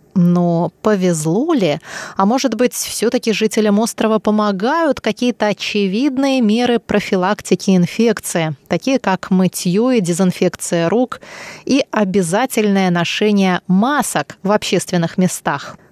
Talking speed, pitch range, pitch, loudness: 105 wpm, 185-230 Hz, 205 Hz, -16 LUFS